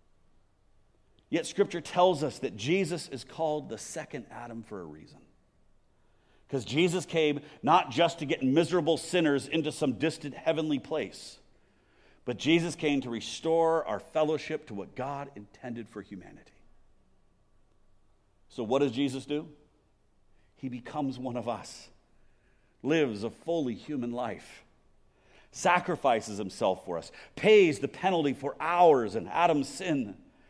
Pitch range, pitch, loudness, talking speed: 110-160 Hz, 140 Hz, -29 LUFS, 135 wpm